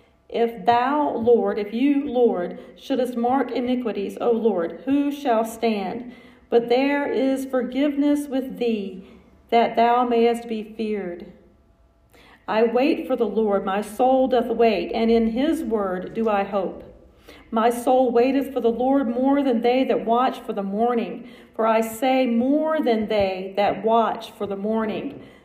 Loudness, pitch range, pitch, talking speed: -22 LUFS, 220-255 Hz, 235 Hz, 155 wpm